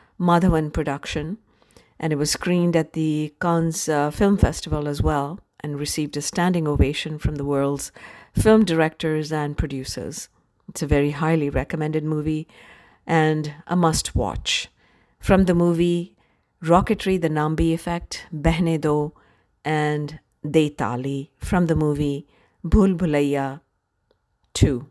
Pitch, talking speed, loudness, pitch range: 155 Hz, 130 wpm, -22 LUFS, 145-170 Hz